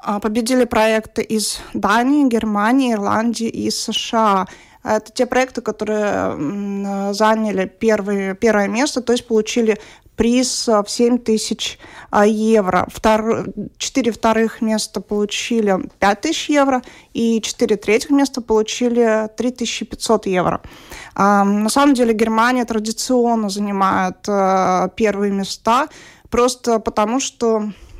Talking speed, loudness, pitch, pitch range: 105 wpm, -17 LUFS, 220 Hz, 210-240 Hz